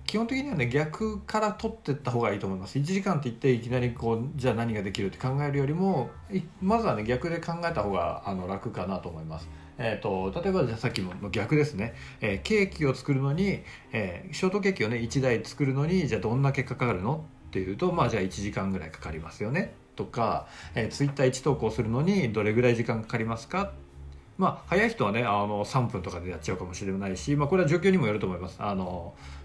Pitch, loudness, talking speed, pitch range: 120 Hz, -29 LUFS, 455 characters per minute, 100-150 Hz